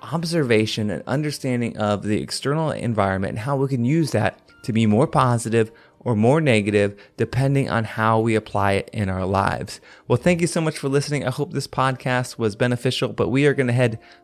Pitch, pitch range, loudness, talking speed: 120 Hz, 110-140 Hz, -21 LUFS, 200 wpm